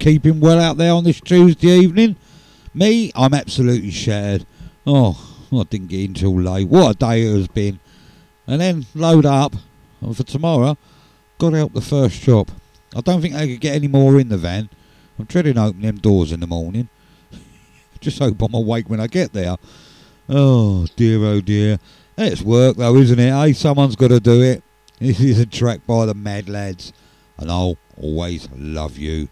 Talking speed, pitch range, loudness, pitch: 190 wpm, 100-145 Hz, -16 LUFS, 120 Hz